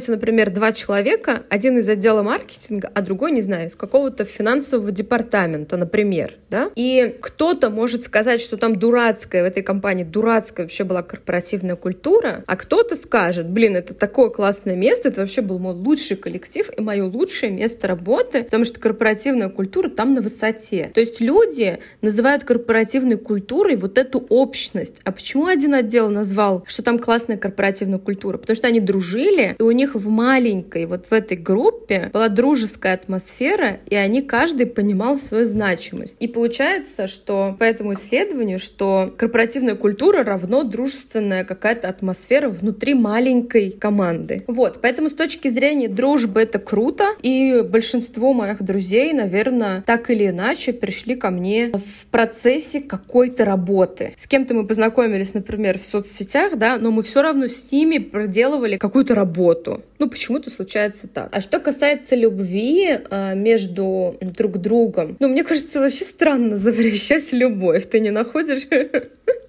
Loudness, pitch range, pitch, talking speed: -19 LUFS, 200-255 Hz, 225 Hz, 150 wpm